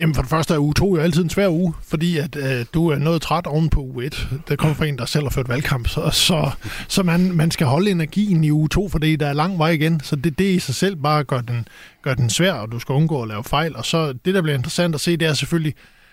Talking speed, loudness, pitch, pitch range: 295 wpm, -19 LUFS, 155 Hz, 140-170 Hz